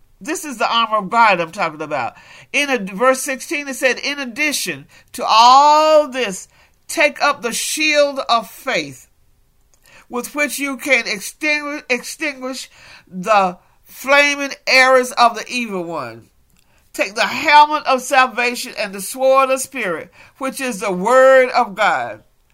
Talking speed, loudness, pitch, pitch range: 140 wpm, -16 LUFS, 260 Hz, 230-285 Hz